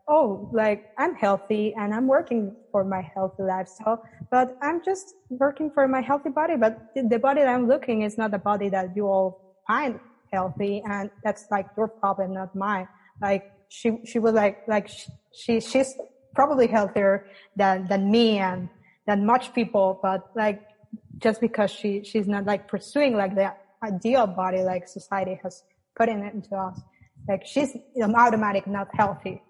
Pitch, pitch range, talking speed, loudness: 210 Hz, 195-235 Hz, 175 wpm, -25 LUFS